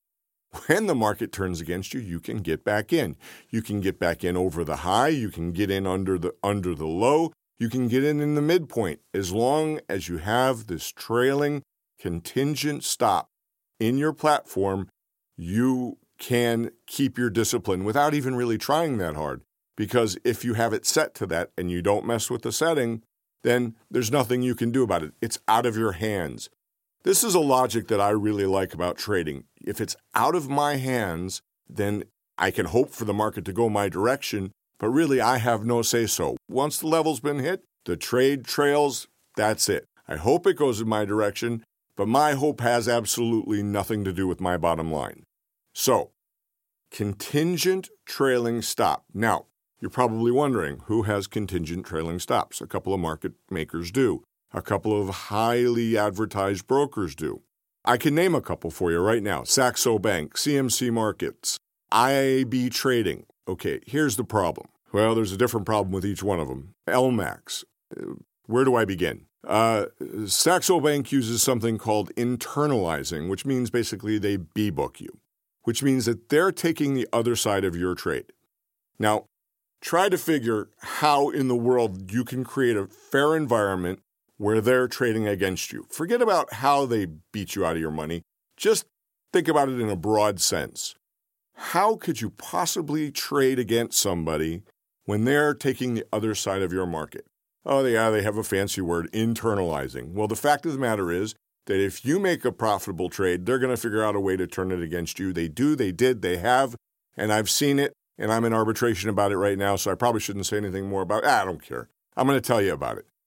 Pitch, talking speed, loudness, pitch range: 110 Hz, 190 wpm, -25 LUFS, 95-130 Hz